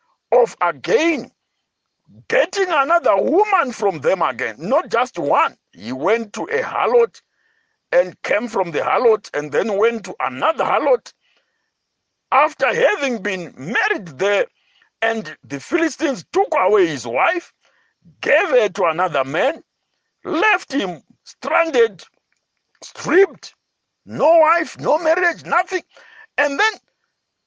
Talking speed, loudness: 120 wpm, -18 LUFS